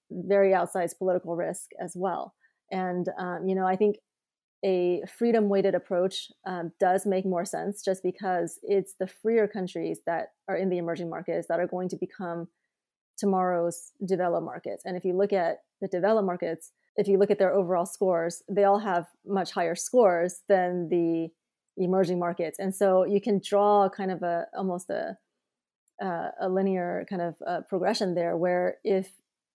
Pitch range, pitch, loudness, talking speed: 175-195 Hz, 185 Hz, -28 LUFS, 175 wpm